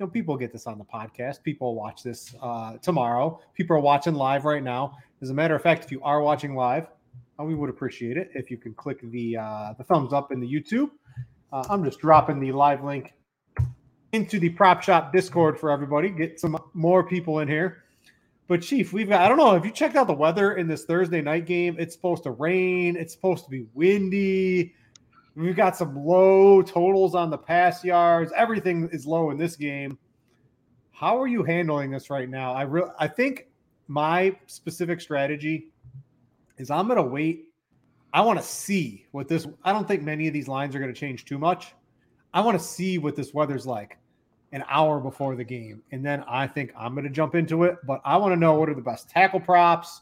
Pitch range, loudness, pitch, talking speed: 135-175 Hz, -24 LUFS, 155 Hz, 210 wpm